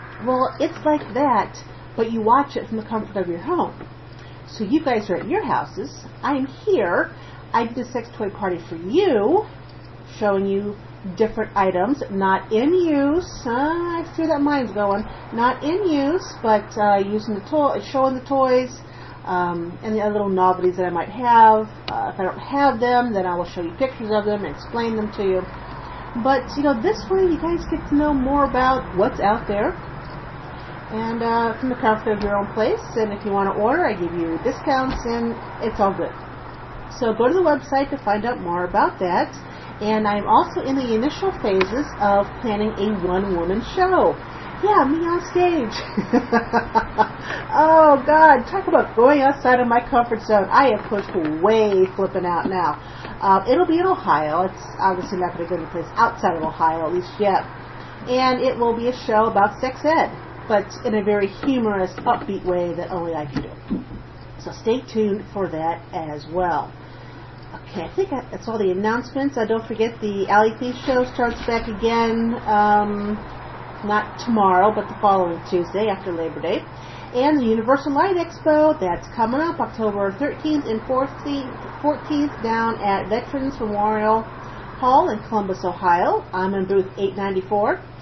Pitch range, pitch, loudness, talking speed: 195-270 Hz, 220 Hz, -20 LUFS, 180 wpm